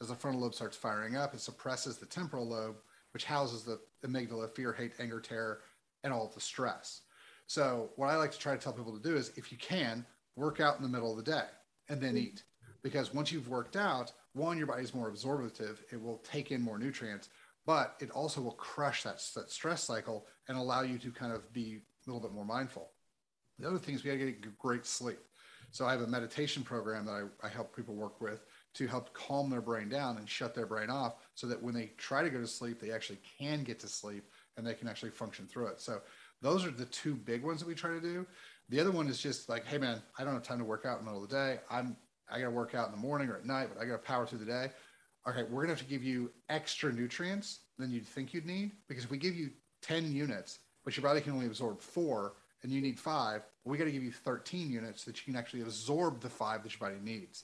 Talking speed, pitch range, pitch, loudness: 260 wpm, 115-140 Hz, 125 Hz, -39 LUFS